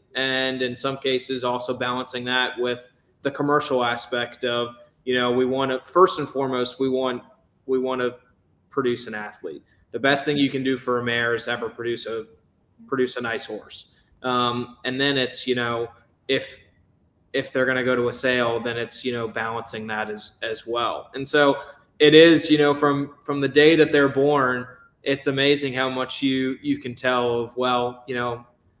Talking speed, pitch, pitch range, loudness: 195 wpm, 125 Hz, 120-135 Hz, -22 LUFS